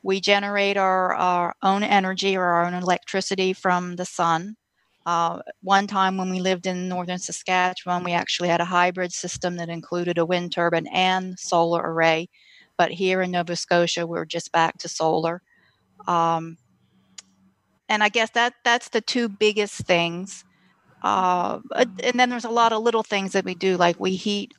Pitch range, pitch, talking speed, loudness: 170-195 Hz, 180 Hz, 175 wpm, -22 LUFS